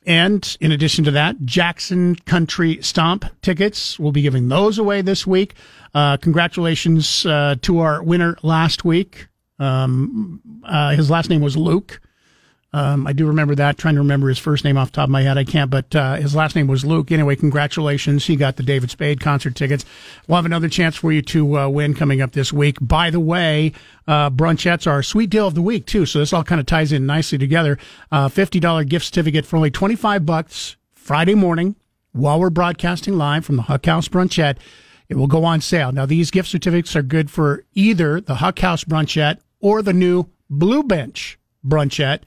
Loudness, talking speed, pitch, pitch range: -17 LUFS, 205 wpm, 160 Hz, 145-175 Hz